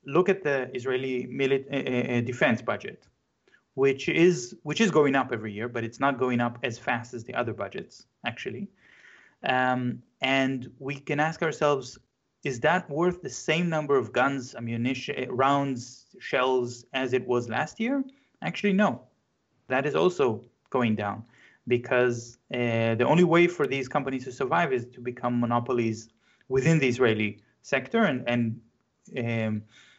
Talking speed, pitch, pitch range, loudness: 155 wpm, 130 Hz, 120-145 Hz, -27 LUFS